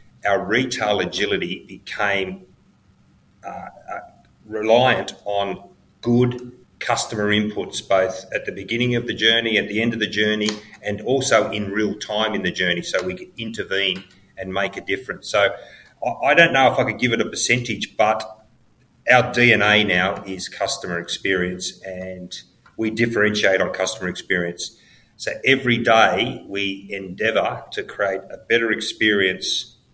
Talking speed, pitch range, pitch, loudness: 150 wpm, 95-110 Hz, 105 Hz, -20 LUFS